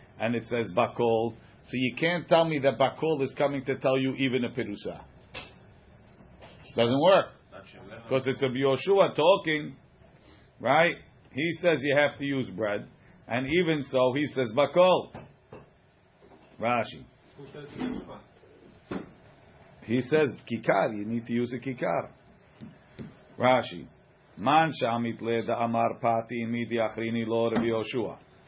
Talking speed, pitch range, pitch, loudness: 125 wpm, 115-140 Hz, 130 Hz, -27 LUFS